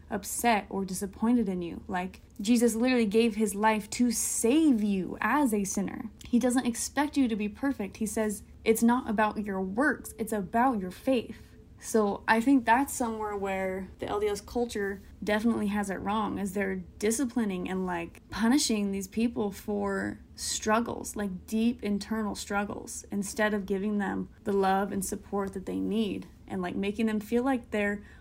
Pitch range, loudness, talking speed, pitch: 200-235 Hz, -29 LUFS, 170 wpm, 215 Hz